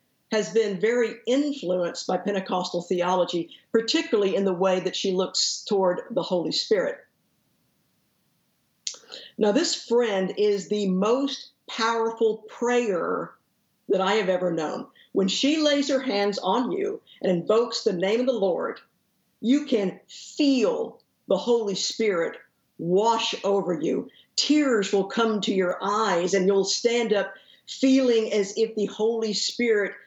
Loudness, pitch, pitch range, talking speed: -24 LUFS, 215 Hz, 190-245 Hz, 140 wpm